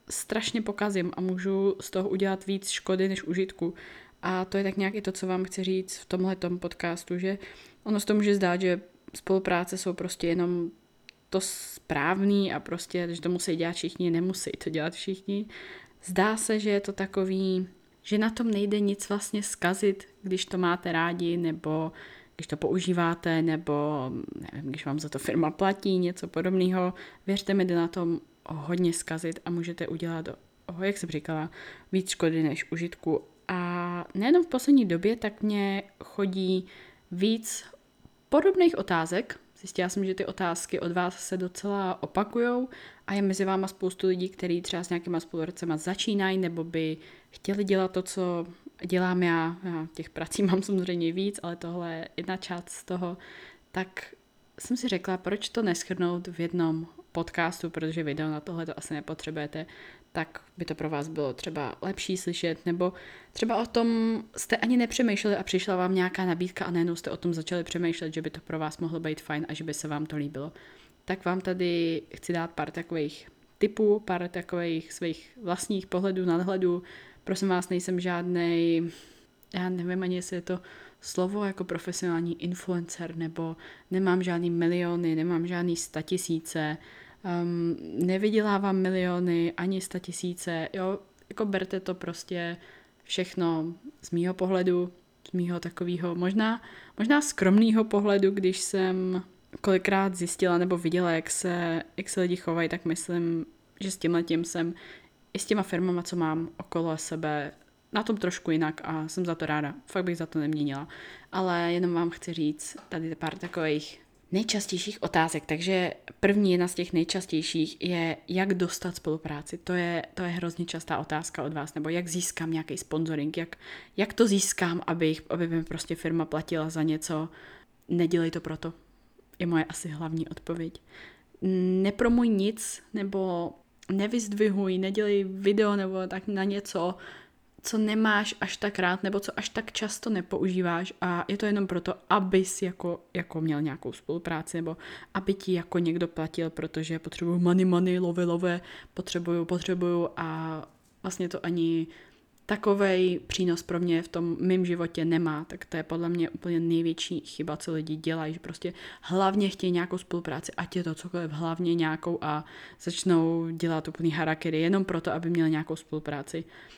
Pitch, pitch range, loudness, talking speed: 175 Hz, 165-190 Hz, -29 LUFS, 165 wpm